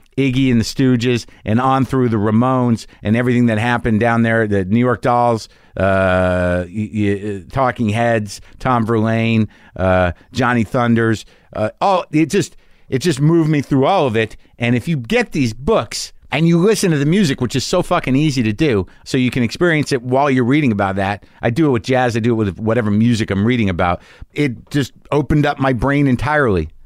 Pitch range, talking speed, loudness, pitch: 110-140 Hz, 190 wpm, -16 LUFS, 120 Hz